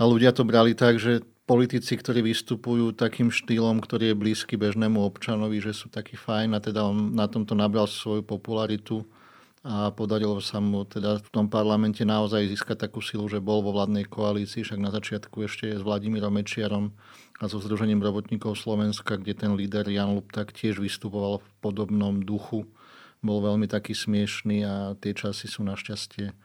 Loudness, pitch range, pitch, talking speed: -27 LUFS, 105-110 Hz, 105 Hz, 175 wpm